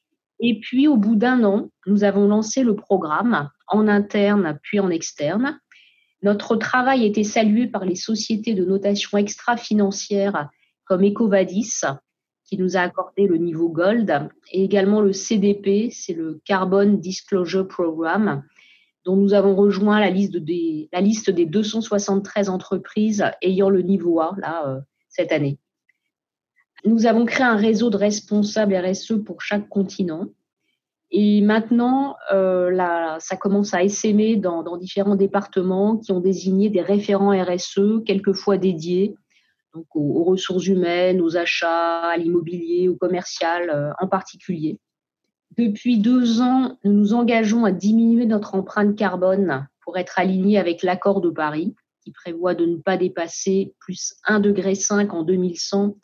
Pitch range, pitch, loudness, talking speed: 180-210 Hz, 195 Hz, -20 LUFS, 140 wpm